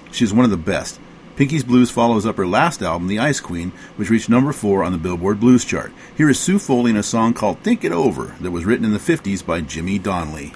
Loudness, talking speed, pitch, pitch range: -18 LUFS, 250 wpm, 110 Hz, 90-125 Hz